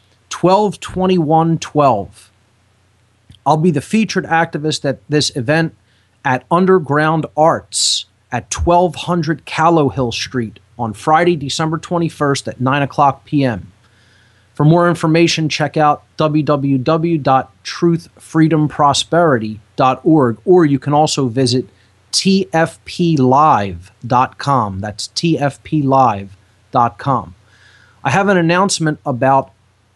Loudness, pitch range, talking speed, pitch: -15 LUFS, 110-160 Hz, 95 wpm, 140 Hz